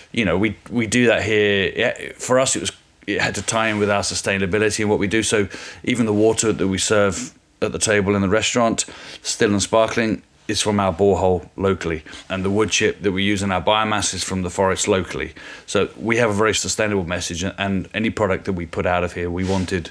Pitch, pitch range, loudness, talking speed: 100 Hz, 95-110 Hz, -20 LUFS, 230 wpm